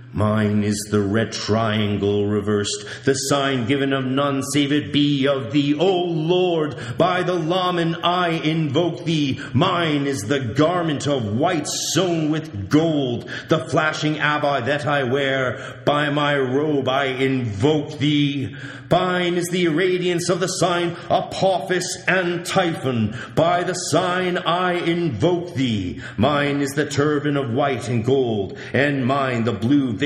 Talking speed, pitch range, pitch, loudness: 150 wpm, 130-170 Hz, 145 Hz, -20 LUFS